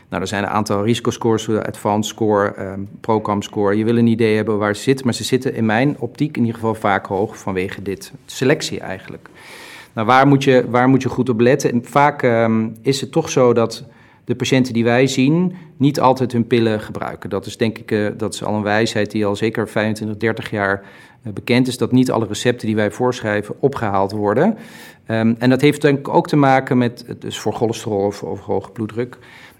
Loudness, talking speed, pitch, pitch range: -18 LUFS, 215 wpm, 115 Hz, 105-125 Hz